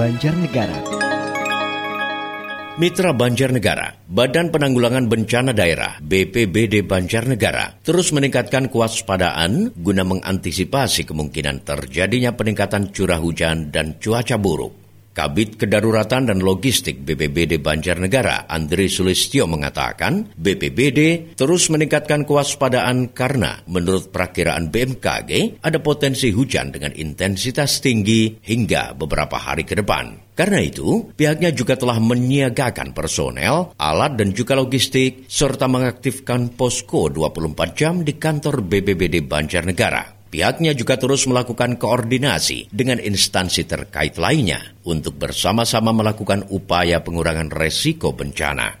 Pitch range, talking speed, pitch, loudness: 90-130 Hz, 105 wpm, 110 Hz, -18 LUFS